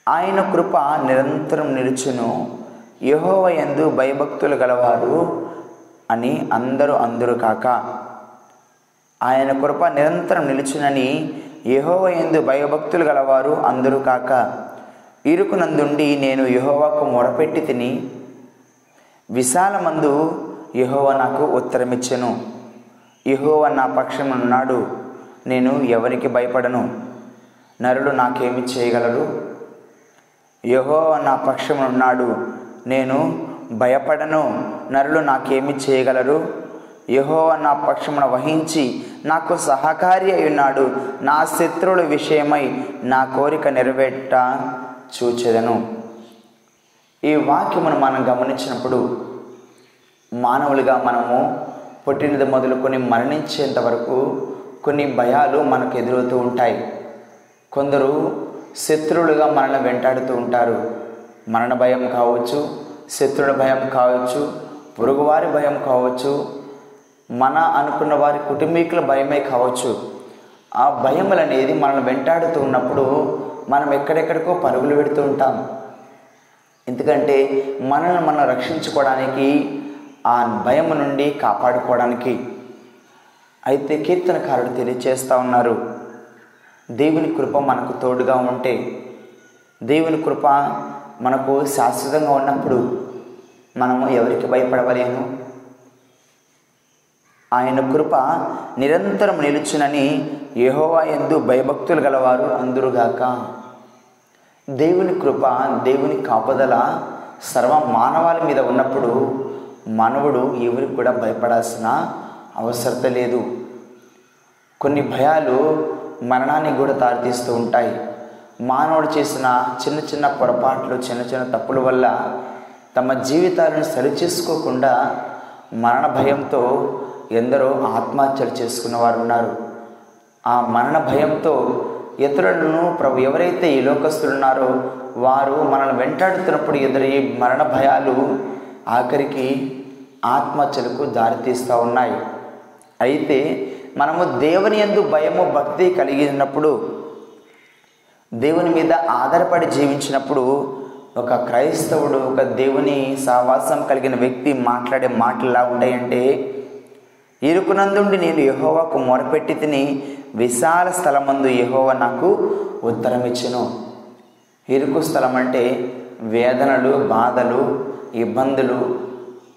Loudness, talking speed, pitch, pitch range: -18 LUFS, 85 wpm, 135 Hz, 125-145 Hz